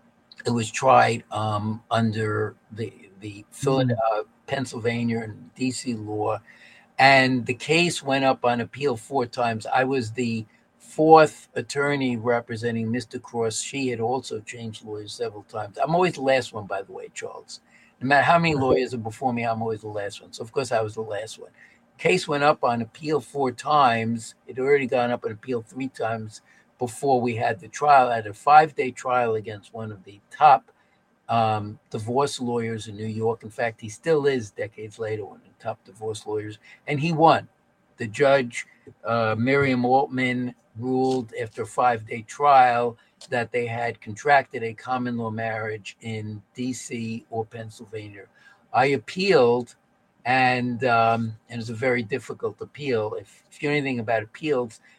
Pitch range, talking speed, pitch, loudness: 110-130 Hz, 175 wpm, 120 Hz, -23 LUFS